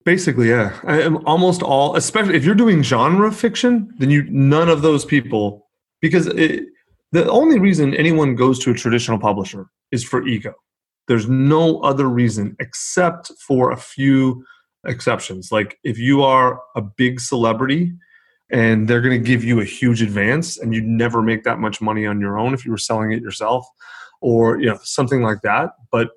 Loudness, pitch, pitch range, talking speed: -17 LUFS, 130 Hz, 115-160 Hz, 185 wpm